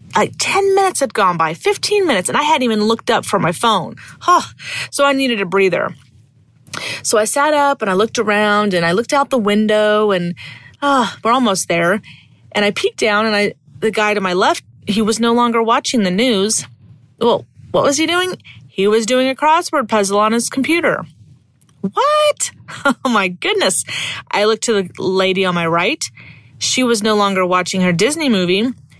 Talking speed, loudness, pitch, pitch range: 195 wpm, -15 LUFS, 215 Hz, 190-265 Hz